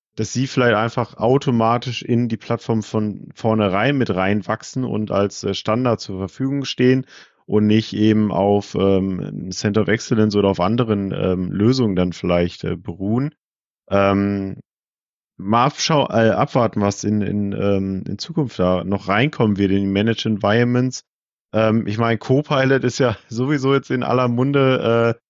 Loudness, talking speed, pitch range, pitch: -19 LUFS, 155 wpm, 100-125 Hz, 110 Hz